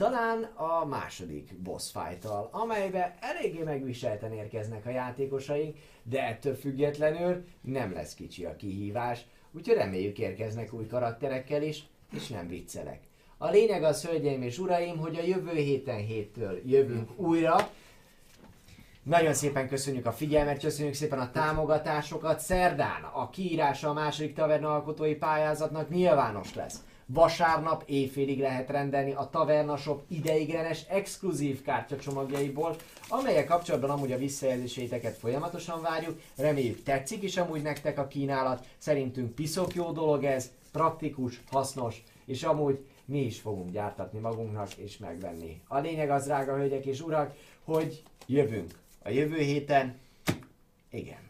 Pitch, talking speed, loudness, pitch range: 140 Hz, 130 wpm, -31 LUFS, 125-155 Hz